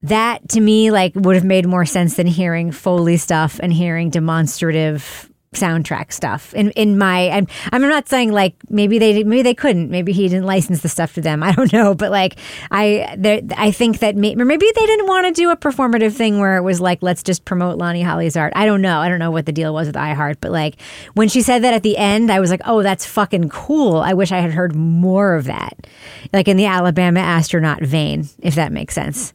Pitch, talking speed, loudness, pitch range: 185 Hz, 235 wpm, -15 LUFS, 170-215 Hz